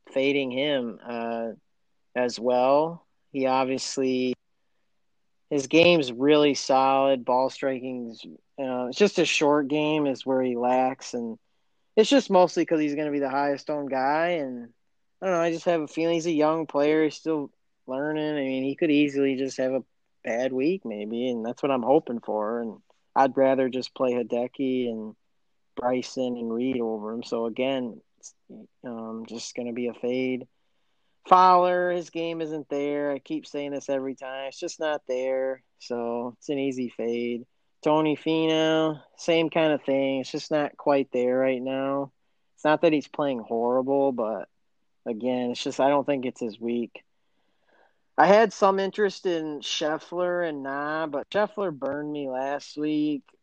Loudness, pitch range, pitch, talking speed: -25 LUFS, 125-155 Hz, 135 Hz, 170 wpm